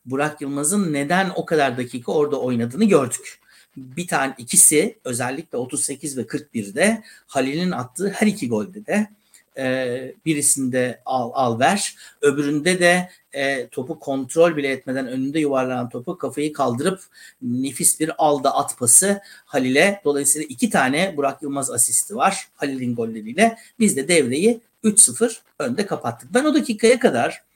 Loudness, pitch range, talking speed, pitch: -20 LUFS, 135-195 Hz, 140 wpm, 150 Hz